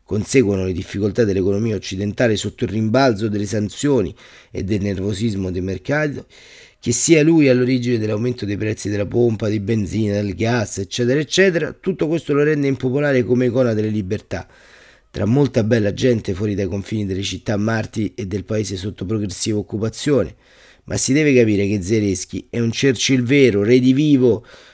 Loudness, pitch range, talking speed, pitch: -18 LUFS, 100-125 Hz, 165 wpm, 110 Hz